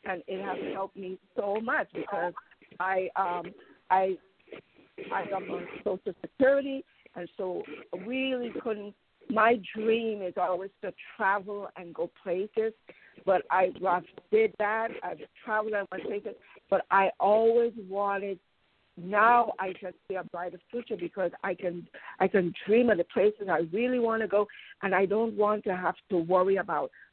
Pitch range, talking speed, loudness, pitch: 185-230 Hz, 155 wpm, -29 LUFS, 200 Hz